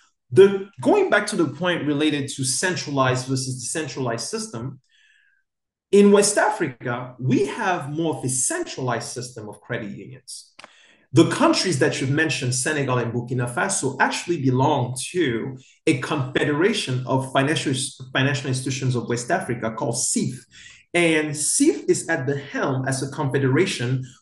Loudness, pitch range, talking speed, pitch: -22 LUFS, 130-165 Hz, 140 wpm, 140 Hz